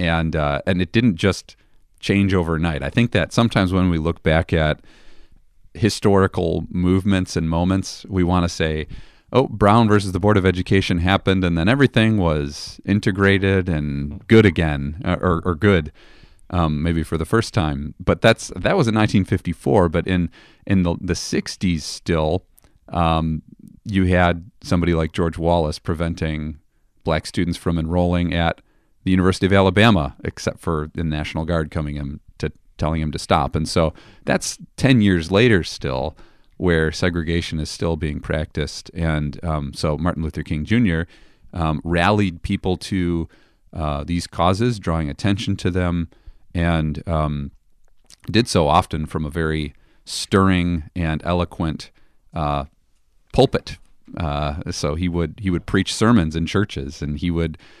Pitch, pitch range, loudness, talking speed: 85 Hz, 80-95 Hz, -20 LUFS, 155 wpm